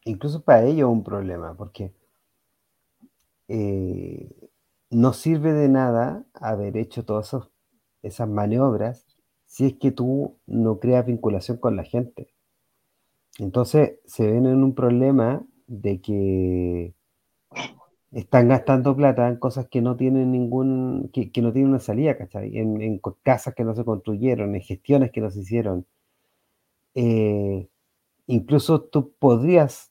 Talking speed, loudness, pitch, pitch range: 135 wpm, -22 LUFS, 120 Hz, 105-130 Hz